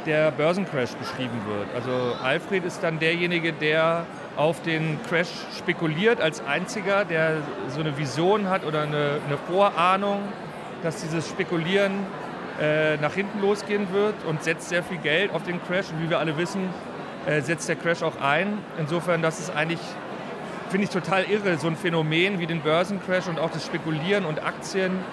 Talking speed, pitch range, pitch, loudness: 175 wpm, 160-190 Hz, 170 Hz, -25 LUFS